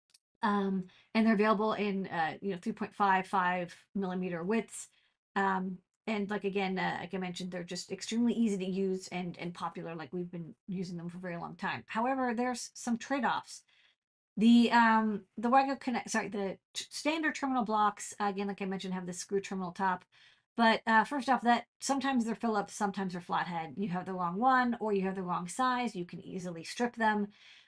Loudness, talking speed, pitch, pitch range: -32 LUFS, 195 wpm, 200 Hz, 185-225 Hz